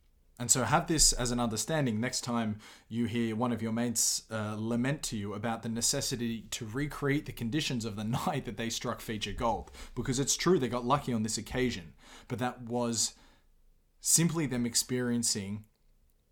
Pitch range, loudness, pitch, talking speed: 110-125 Hz, -31 LUFS, 120 Hz, 180 wpm